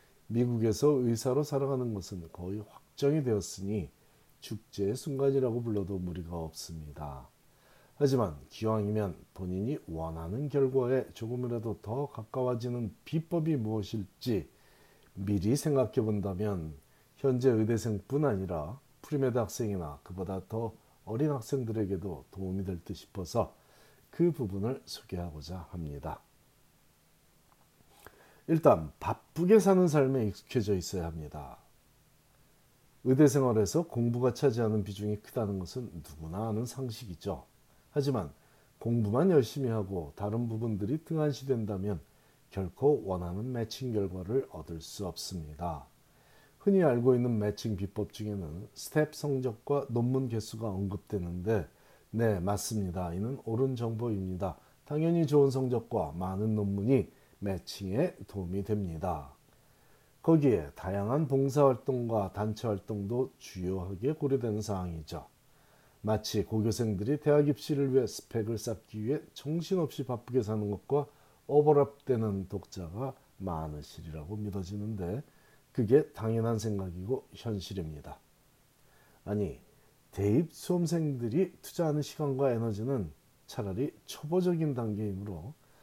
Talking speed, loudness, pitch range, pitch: 285 characters per minute, -32 LUFS, 95-135 Hz, 110 Hz